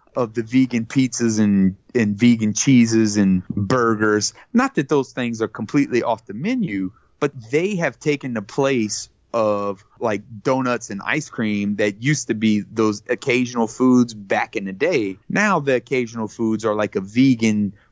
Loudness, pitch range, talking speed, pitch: -20 LUFS, 105-130 Hz, 165 wpm, 115 Hz